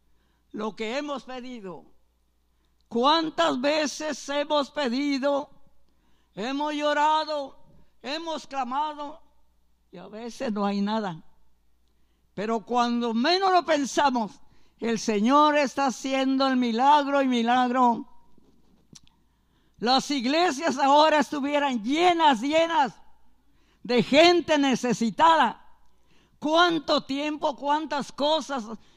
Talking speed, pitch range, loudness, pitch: 90 wpm, 230-300 Hz, -24 LUFS, 275 Hz